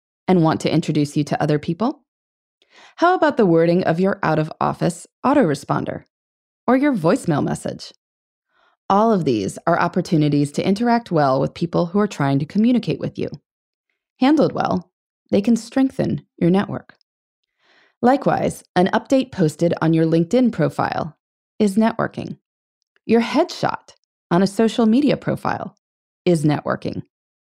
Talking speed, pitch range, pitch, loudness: 140 wpm, 160-235 Hz, 185 Hz, -19 LUFS